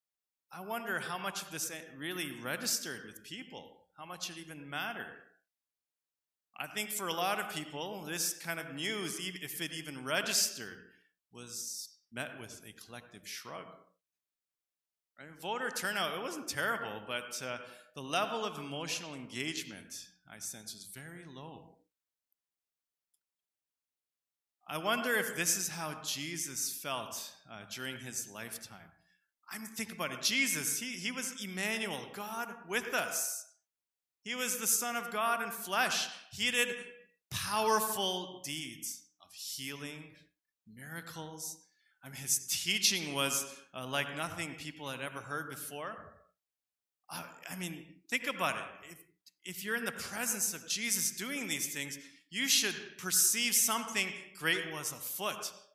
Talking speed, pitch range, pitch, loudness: 140 wpm, 140-210 Hz, 165 Hz, -34 LUFS